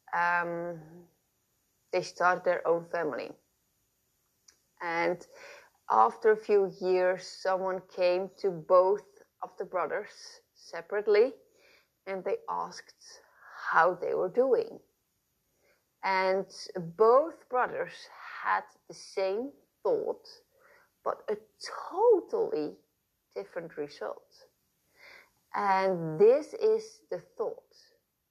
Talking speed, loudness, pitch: 90 wpm, -30 LUFS, 330 Hz